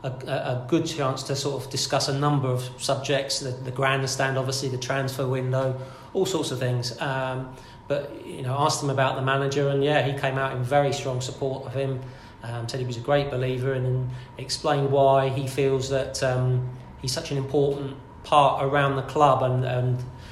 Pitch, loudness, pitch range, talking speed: 135 Hz, -25 LUFS, 130-140 Hz, 200 wpm